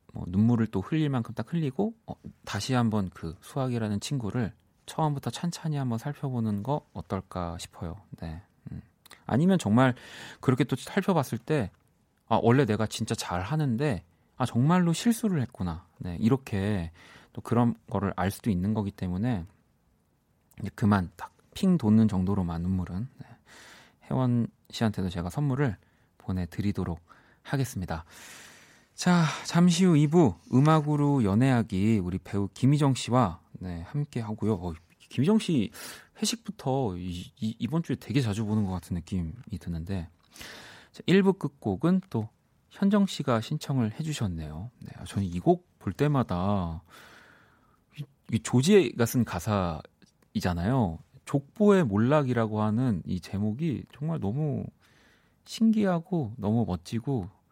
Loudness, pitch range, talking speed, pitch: -28 LUFS, 95-145 Hz, 270 characters per minute, 115 Hz